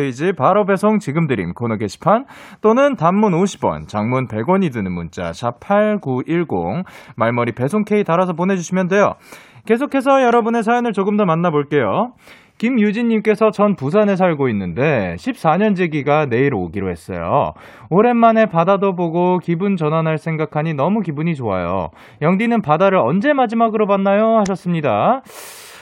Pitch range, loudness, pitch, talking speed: 140-215 Hz, -17 LUFS, 185 Hz, 315 characters per minute